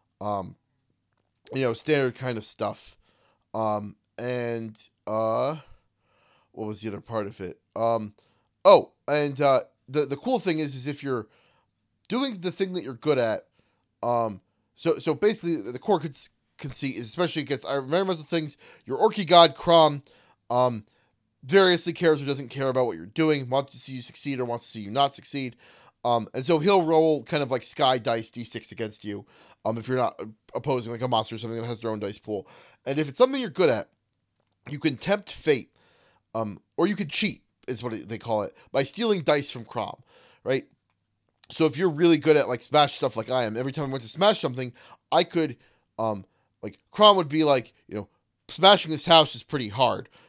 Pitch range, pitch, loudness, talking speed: 115-160 Hz, 135 Hz, -24 LUFS, 200 wpm